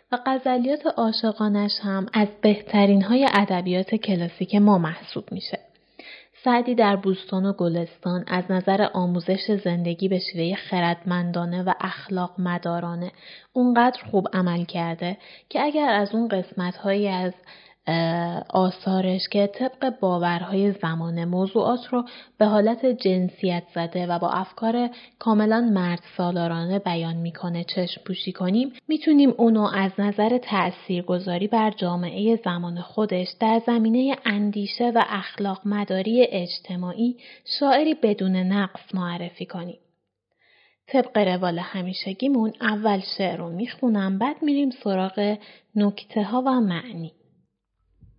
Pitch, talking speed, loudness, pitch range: 195 Hz, 120 wpm, -23 LUFS, 180-225 Hz